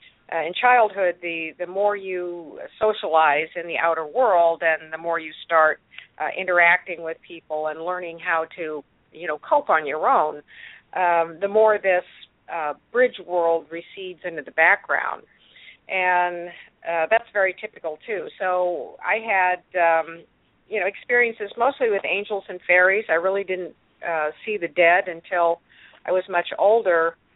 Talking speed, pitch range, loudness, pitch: 160 wpm, 165-195 Hz, -22 LUFS, 180 Hz